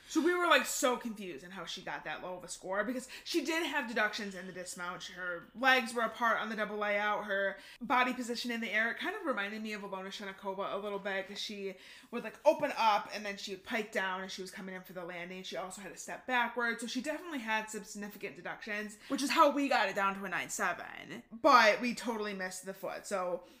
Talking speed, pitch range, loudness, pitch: 250 wpm, 195-250 Hz, -34 LUFS, 210 Hz